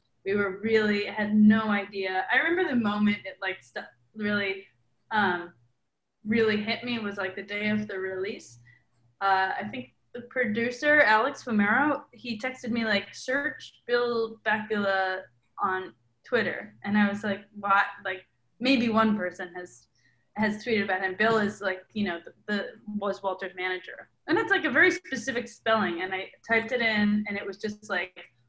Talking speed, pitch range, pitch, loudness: 175 wpm, 190-225 Hz, 205 Hz, -27 LUFS